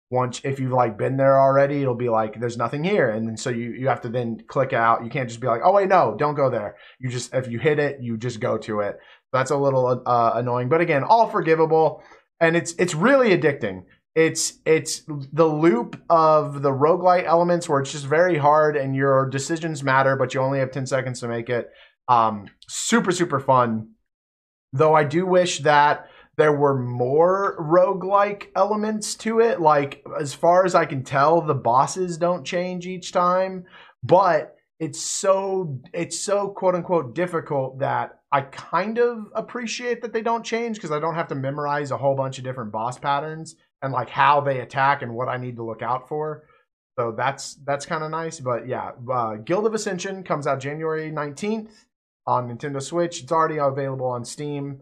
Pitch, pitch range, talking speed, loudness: 145 Hz, 130-175 Hz, 195 wpm, -22 LUFS